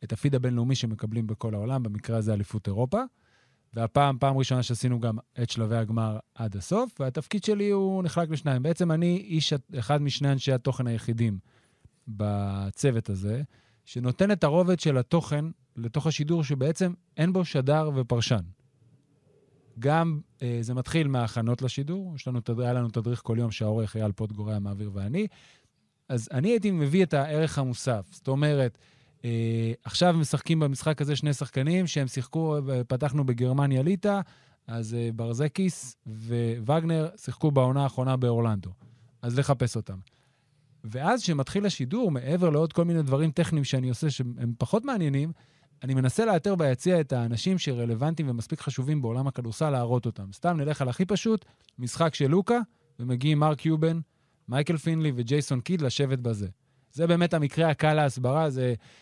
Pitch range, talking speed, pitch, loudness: 120-160 Hz, 150 wpm, 135 Hz, -27 LUFS